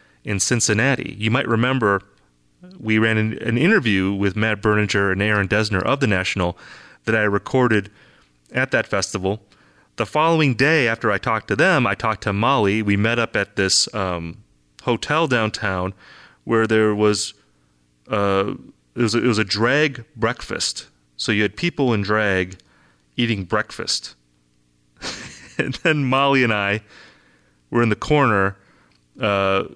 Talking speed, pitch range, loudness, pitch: 150 wpm, 95-115 Hz, -20 LUFS, 105 Hz